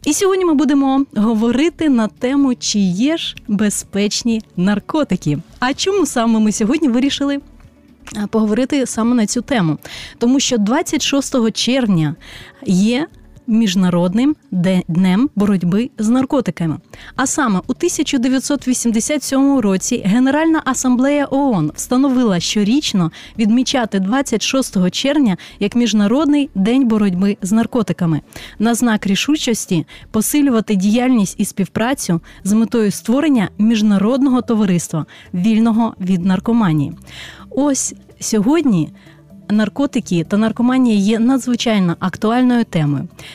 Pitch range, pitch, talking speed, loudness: 195-265 Hz, 230 Hz, 105 wpm, -16 LUFS